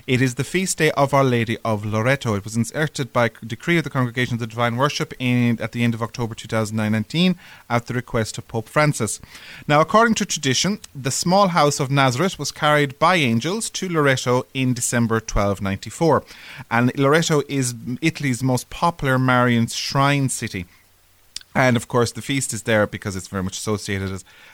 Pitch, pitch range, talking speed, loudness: 125 Hz, 115-145 Hz, 185 wpm, -20 LUFS